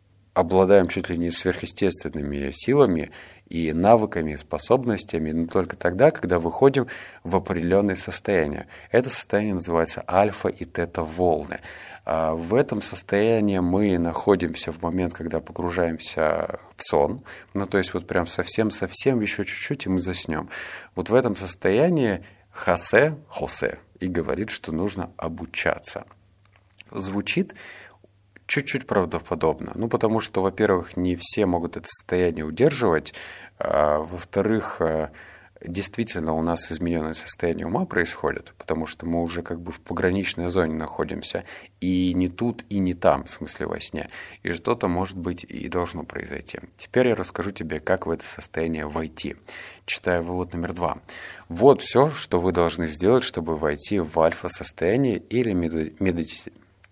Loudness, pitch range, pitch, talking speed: -24 LUFS, 85-100 Hz, 90 Hz, 140 wpm